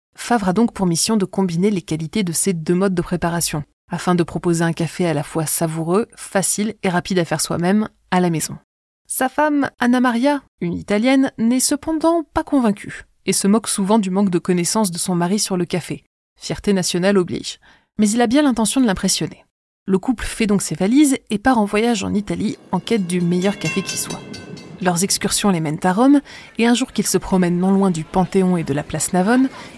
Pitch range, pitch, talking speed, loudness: 175-230 Hz, 195 Hz, 215 wpm, -18 LUFS